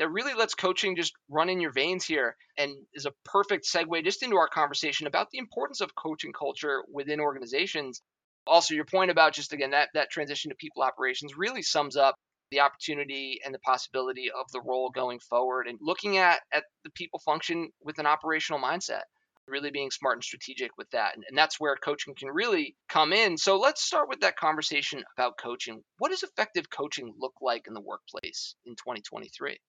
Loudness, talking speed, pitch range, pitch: -28 LUFS, 200 wpm, 140-185 Hz, 155 Hz